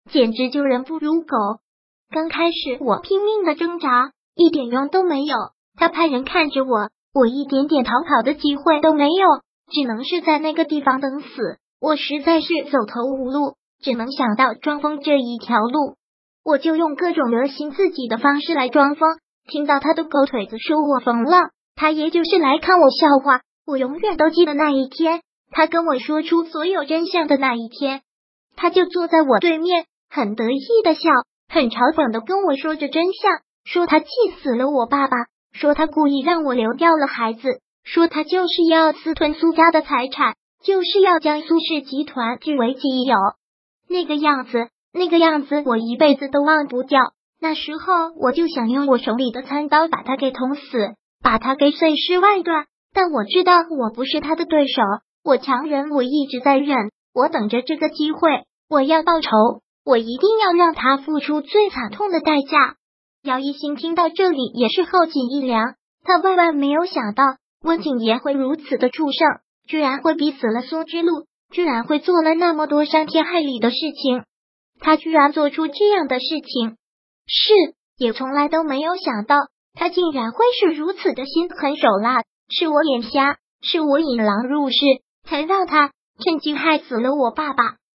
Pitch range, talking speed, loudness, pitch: 260-330 Hz, 260 characters per minute, -18 LUFS, 300 Hz